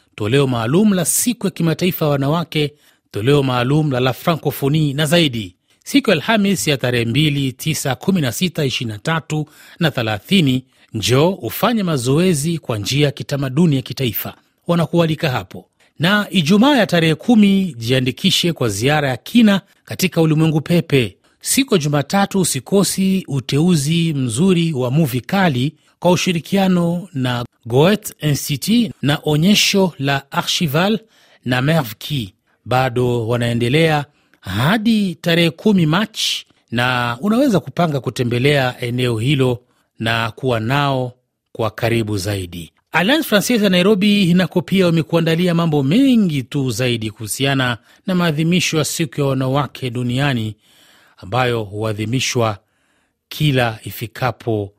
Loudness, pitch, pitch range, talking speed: -17 LUFS, 145 Hz, 125-175 Hz, 115 wpm